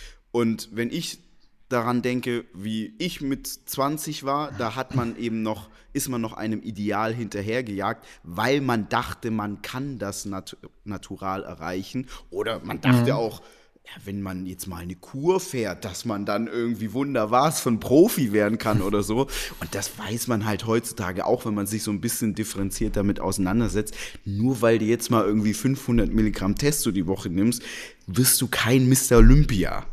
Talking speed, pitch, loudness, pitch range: 175 wpm, 110 Hz, -24 LUFS, 100-125 Hz